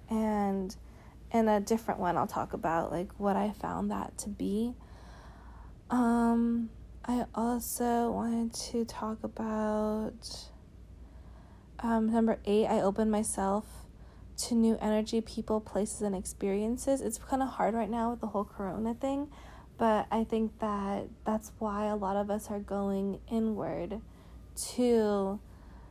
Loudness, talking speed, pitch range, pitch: -32 LUFS, 140 wpm, 200-230 Hz, 215 Hz